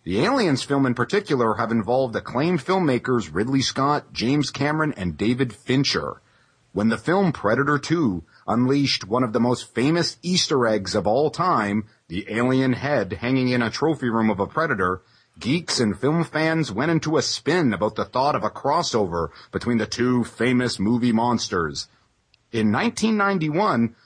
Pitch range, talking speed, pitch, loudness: 115-150 Hz, 160 wpm, 125 Hz, -22 LUFS